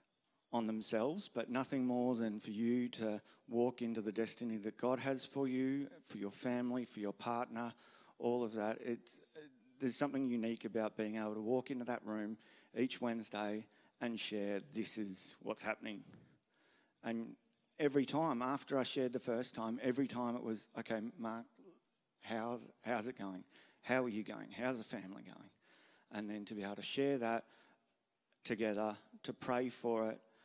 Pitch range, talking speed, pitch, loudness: 110-125 Hz, 170 wpm, 115 Hz, -41 LUFS